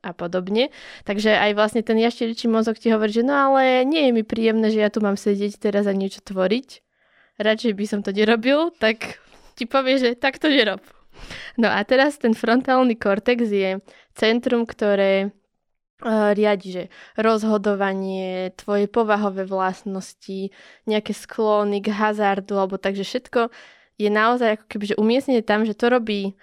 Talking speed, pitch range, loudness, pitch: 160 wpm, 205-240 Hz, -21 LUFS, 215 Hz